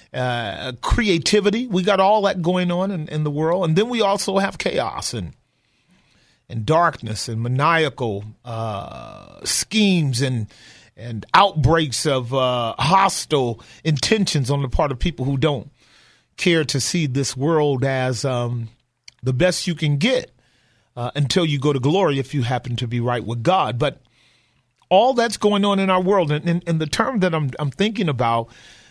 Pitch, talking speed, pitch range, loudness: 145 Hz, 165 wpm, 120-180 Hz, -20 LUFS